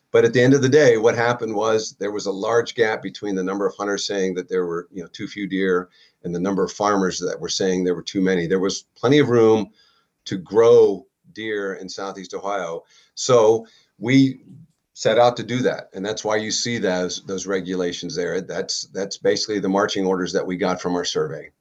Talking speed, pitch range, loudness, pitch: 220 wpm, 95-120 Hz, -21 LUFS, 100 Hz